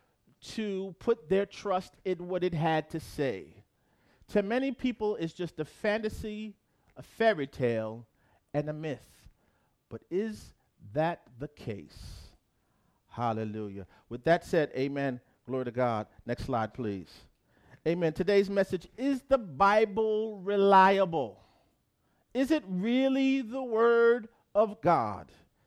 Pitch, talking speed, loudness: 170 Hz, 125 wpm, -30 LUFS